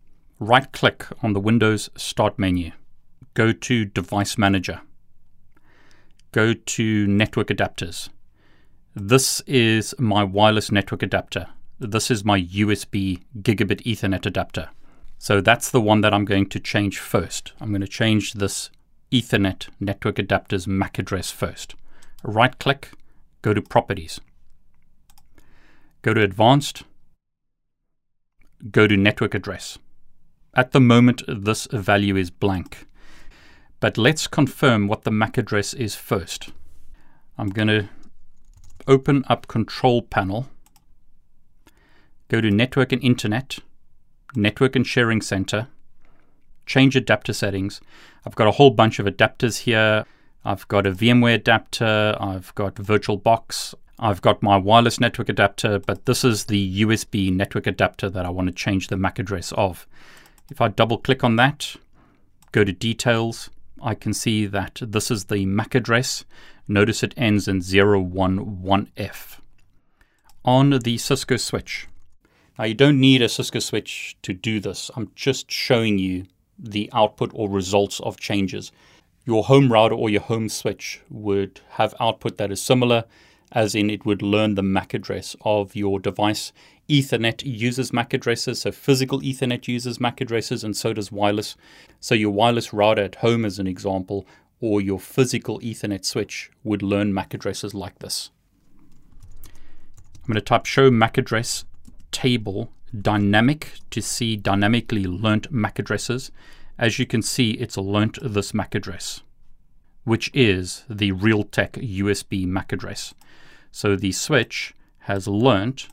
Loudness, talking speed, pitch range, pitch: -21 LUFS, 140 wpm, 100-120 Hz, 105 Hz